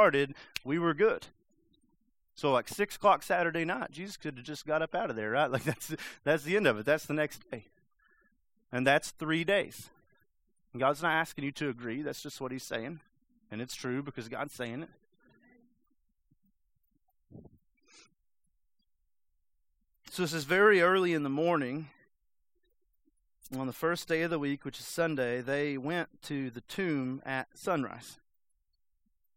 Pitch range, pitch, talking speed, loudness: 135-180 Hz, 150 Hz, 160 wpm, -32 LUFS